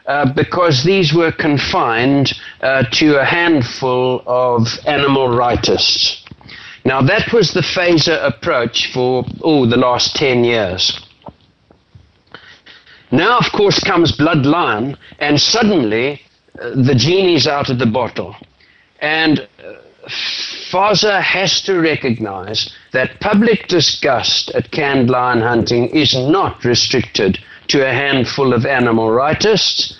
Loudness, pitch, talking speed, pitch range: -14 LUFS, 135 Hz, 125 wpm, 125-160 Hz